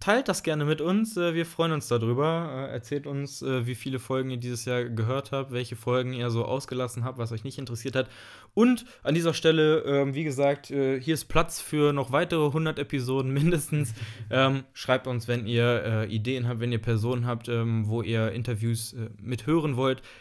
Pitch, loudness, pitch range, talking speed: 130 Hz, -27 LUFS, 120-150 Hz, 180 wpm